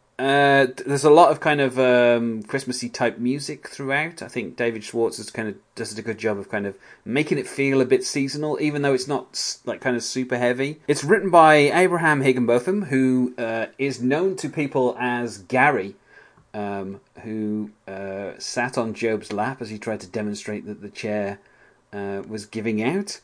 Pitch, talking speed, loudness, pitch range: 125 Hz, 190 wpm, -22 LUFS, 110-140 Hz